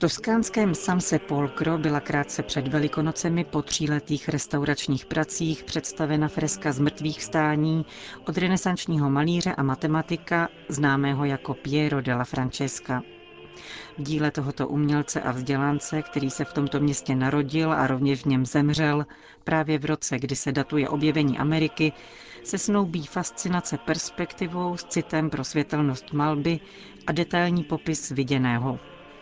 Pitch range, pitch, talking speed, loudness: 140-160 Hz, 150 Hz, 130 wpm, -26 LUFS